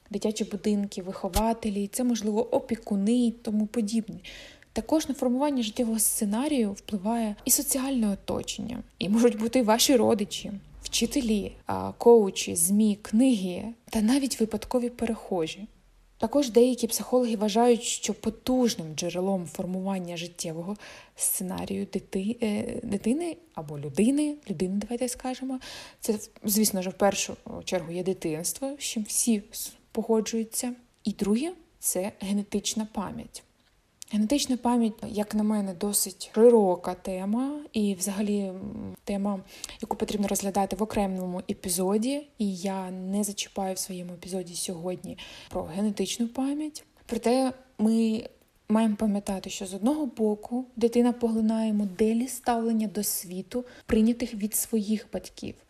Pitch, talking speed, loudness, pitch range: 215 Hz, 120 wpm, -27 LUFS, 200-240 Hz